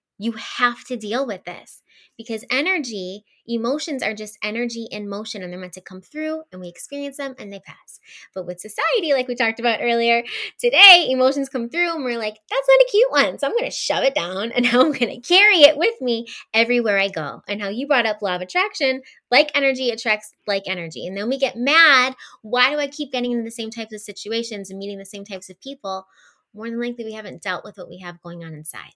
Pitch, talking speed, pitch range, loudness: 230 Hz, 235 wpm, 200-270 Hz, -19 LUFS